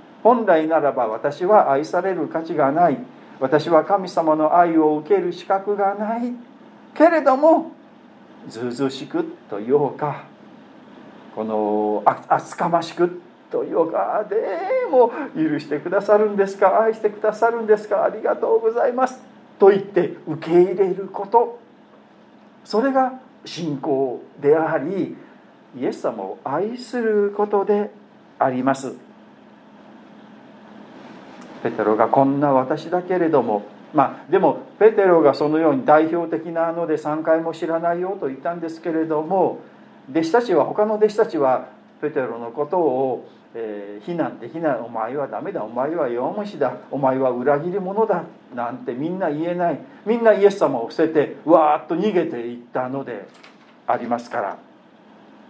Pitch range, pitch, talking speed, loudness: 150-220 Hz, 175 Hz, 275 characters per minute, -20 LUFS